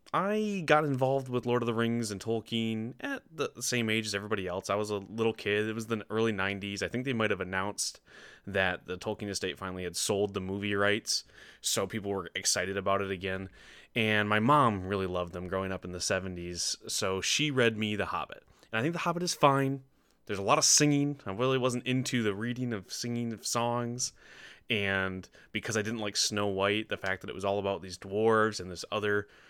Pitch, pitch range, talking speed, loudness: 105 Hz, 100-120 Hz, 220 wpm, -30 LUFS